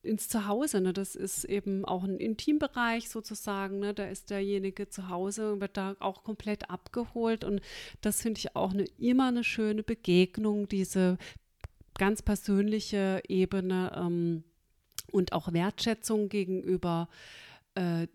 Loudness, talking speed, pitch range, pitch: -31 LUFS, 140 wpm, 185-215 Hz, 200 Hz